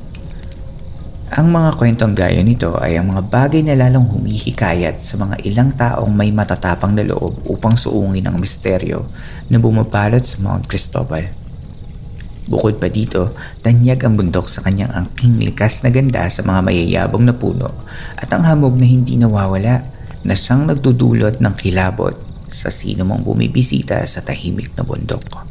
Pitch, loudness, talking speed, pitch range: 105 Hz, -15 LUFS, 155 wpm, 95-120 Hz